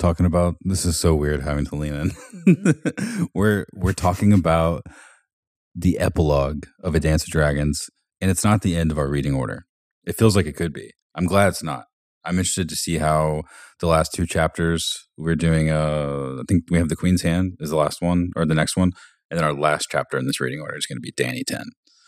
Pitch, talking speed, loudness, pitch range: 85 Hz, 225 wpm, -21 LUFS, 75-95 Hz